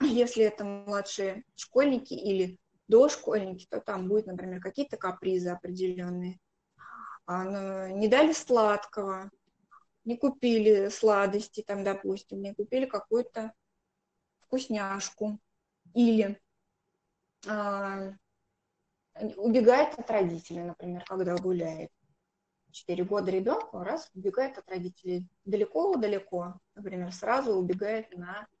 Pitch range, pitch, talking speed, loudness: 185-220 Hz, 200 Hz, 95 wpm, -29 LUFS